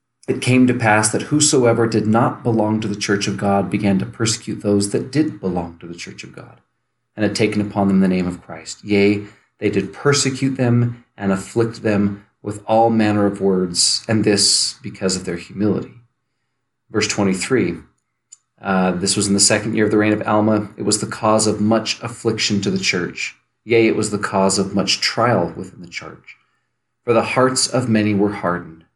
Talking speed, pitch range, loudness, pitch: 200 wpm, 100-115 Hz, -18 LUFS, 105 Hz